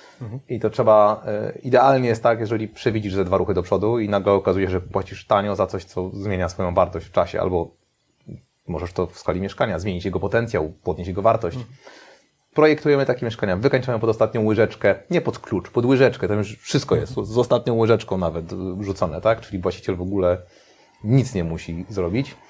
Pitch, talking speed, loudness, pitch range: 105 Hz, 185 wpm, -21 LUFS, 95-120 Hz